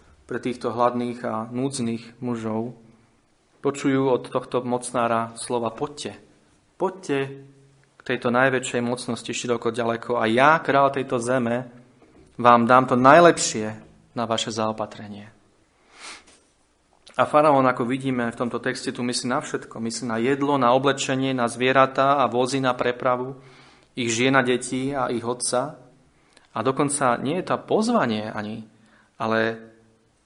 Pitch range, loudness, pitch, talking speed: 115-135 Hz, -22 LUFS, 125 Hz, 135 wpm